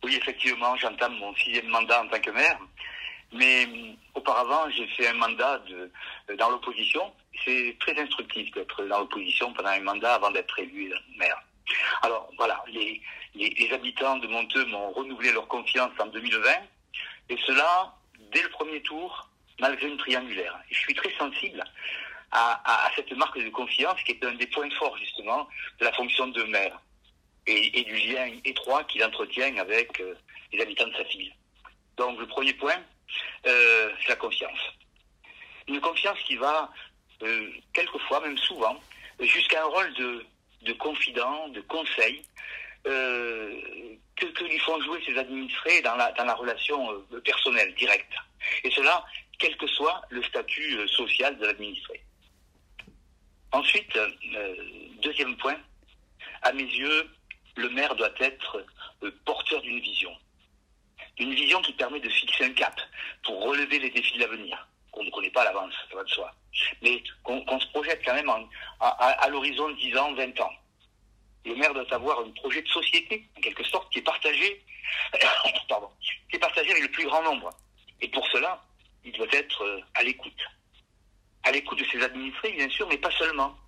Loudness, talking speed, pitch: -26 LUFS, 170 wpm, 135 Hz